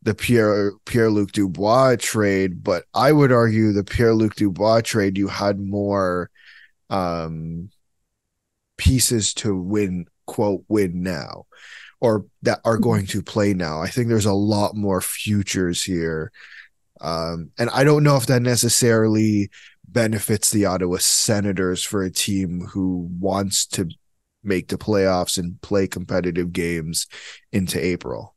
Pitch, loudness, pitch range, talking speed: 100 Hz, -20 LUFS, 90-110 Hz, 140 wpm